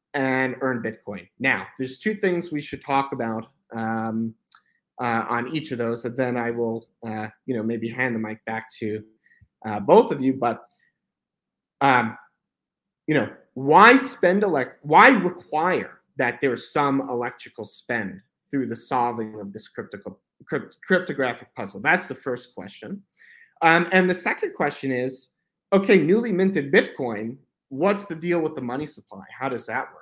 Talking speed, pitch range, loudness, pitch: 165 wpm, 115-165 Hz, -23 LUFS, 130 Hz